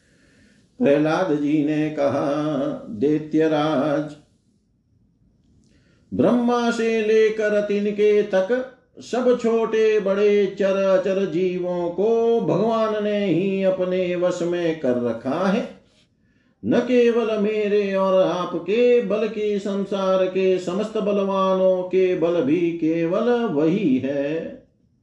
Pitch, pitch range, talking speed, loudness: 190 Hz, 170-215 Hz, 105 wpm, -21 LUFS